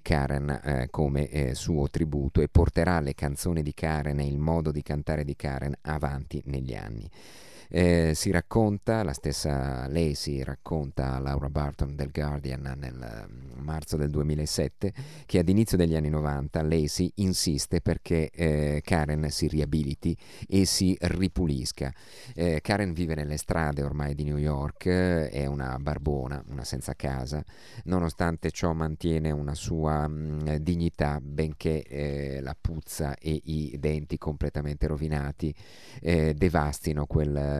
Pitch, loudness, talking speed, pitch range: 75 Hz, -29 LUFS, 145 wpm, 70-85 Hz